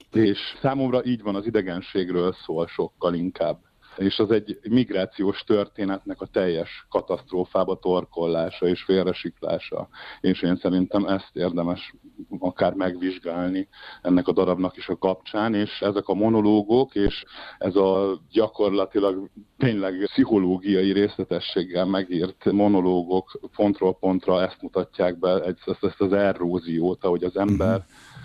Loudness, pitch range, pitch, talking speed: -24 LUFS, 90-100 Hz, 95 Hz, 125 wpm